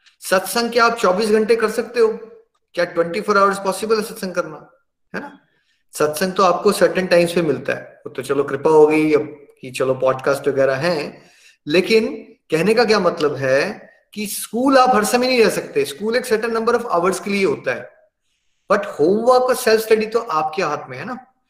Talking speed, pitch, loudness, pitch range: 185 wpm, 205 Hz, -18 LUFS, 160-230 Hz